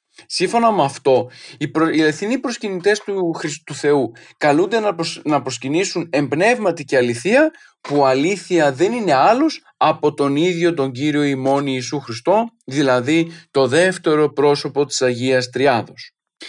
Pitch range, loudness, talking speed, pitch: 140-185 Hz, -18 LUFS, 125 wpm, 155 Hz